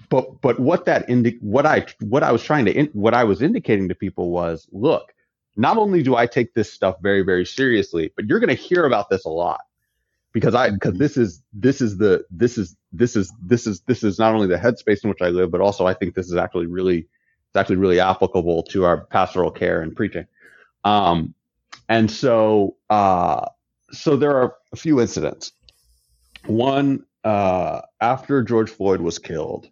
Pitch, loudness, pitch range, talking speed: 105 Hz, -20 LUFS, 90-120 Hz, 205 wpm